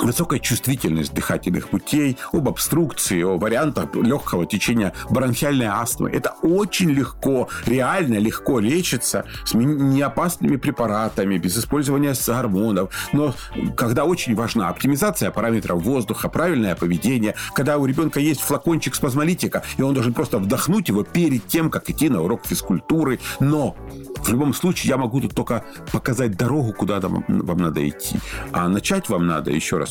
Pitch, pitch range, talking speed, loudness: 130 Hz, 105-145 Hz, 145 wpm, -21 LUFS